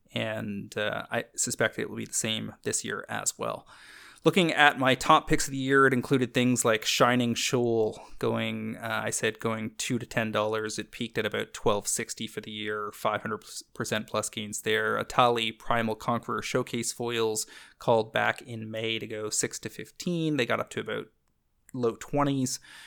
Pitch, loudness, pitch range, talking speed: 115 Hz, -28 LUFS, 110-130 Hz, 185 wpm